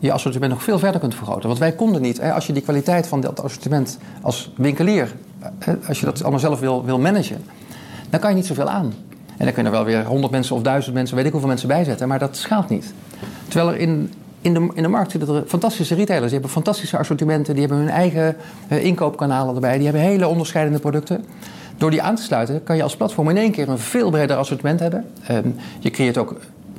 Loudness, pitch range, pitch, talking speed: -20 LUFS, 135-175 Hz, 155 Hz, 230 wpm